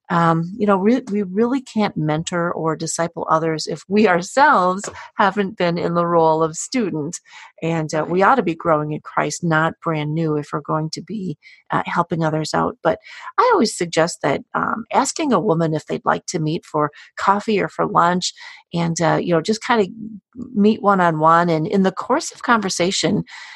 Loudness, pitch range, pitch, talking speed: -19 LUFS, 160-210 Hz, 175 Hz, 200 wpm